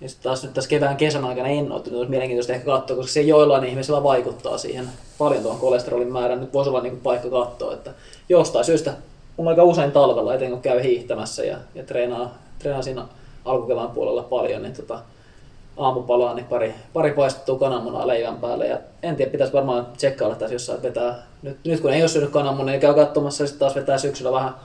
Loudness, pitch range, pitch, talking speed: -21 LUFS, 125-145 Hz, 135 Hz, 195 wpm